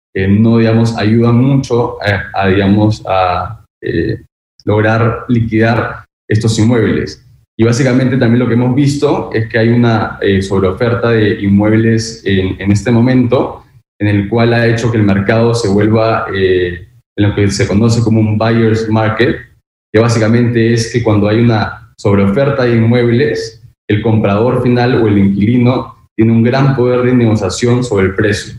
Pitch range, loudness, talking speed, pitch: 105-120 Hz, -11 LUFS, 165 wpm, 115 Hz